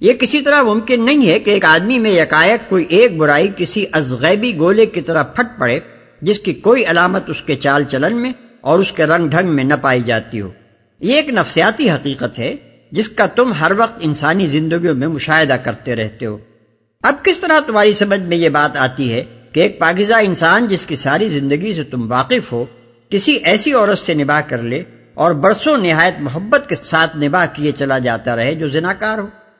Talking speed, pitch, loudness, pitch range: 205 wpm, 165 Hz, -14 LUFS, 140-210 Hz